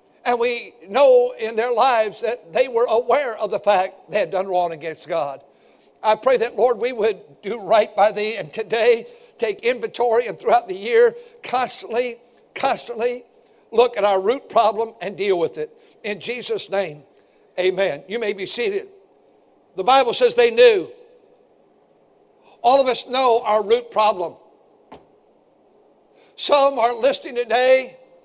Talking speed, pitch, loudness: 155 wpm, 245 Hz, -19 LUFS